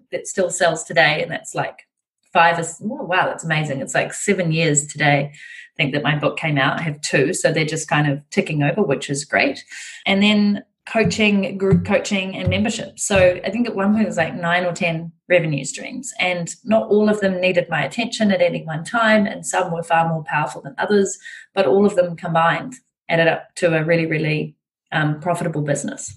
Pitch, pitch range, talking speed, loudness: 175 Hz, 160-205 Hz, 215 wpm, -19 LUFS